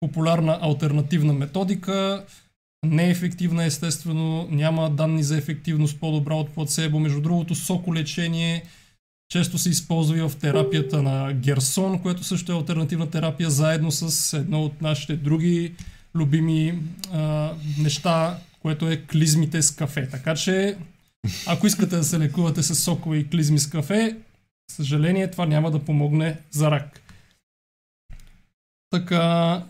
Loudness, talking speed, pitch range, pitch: -23 LUFS, 130 wpm, 150-170 Hz, 160 Hz